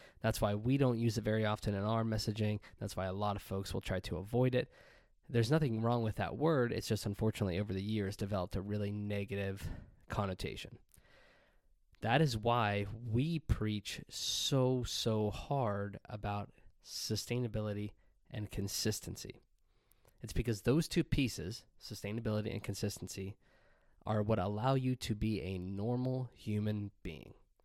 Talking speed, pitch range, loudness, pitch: 150 wpm, 100-120 Hz, -37 LUFS, 105 Hz